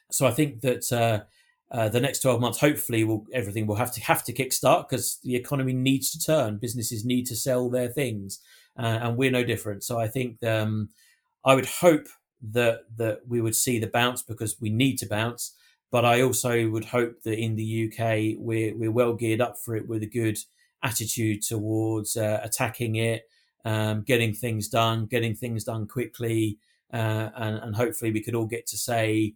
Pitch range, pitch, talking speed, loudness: 110-125 Hz, 115 Hz, 200 wpm, -26 LUFS